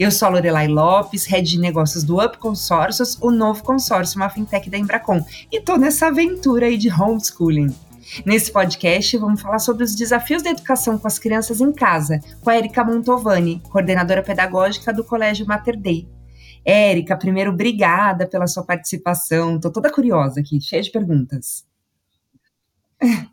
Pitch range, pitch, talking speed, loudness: 170-230 Hz, 200 Hz, 160 wpm, -18 LUFS